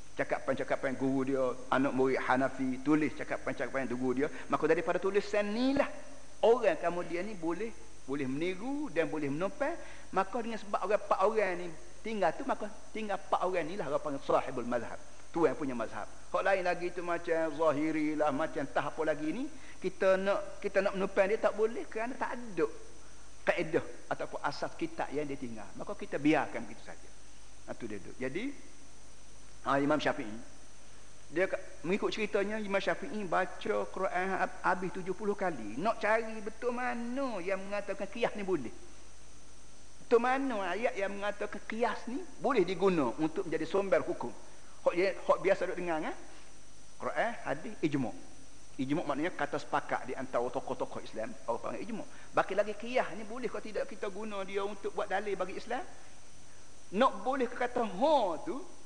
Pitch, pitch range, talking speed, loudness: 195 Hz, 160-230 Hz, 165 wpm, -34 LUFS